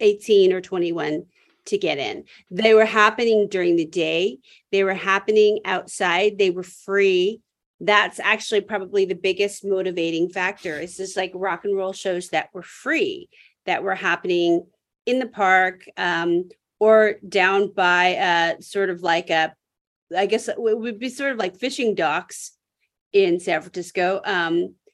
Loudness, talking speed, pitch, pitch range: -21 LUFS, 155 wpm, 195 Hz, 180-220 Hz